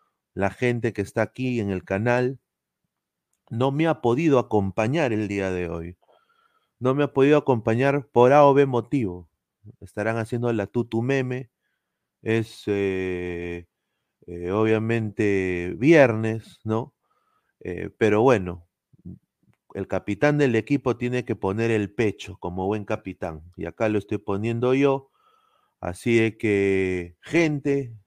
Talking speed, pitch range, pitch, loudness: 135 wpm, 95-130 Hz, 110 Hz, -23 LUFS